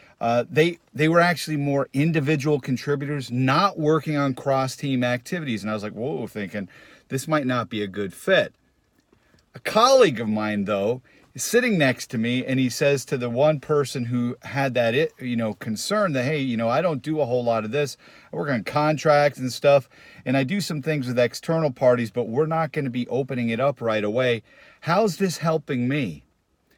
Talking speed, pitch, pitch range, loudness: 205 wpm, 135 Hz, 120-155 Hz, -23 LUFS